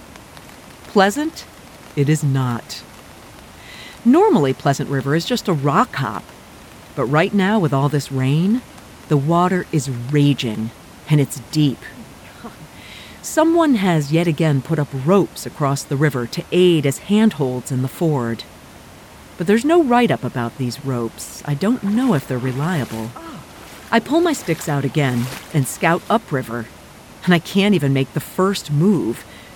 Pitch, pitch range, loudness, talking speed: 150 Hz, 130-185 Hz, -18 LUFS, 150 wpm